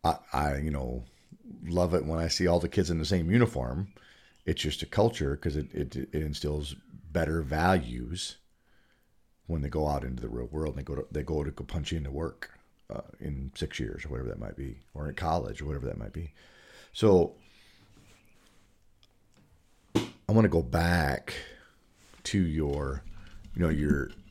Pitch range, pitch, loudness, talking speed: 75-95 Hz, 80 Hz, -31 LUFS, 180 wpm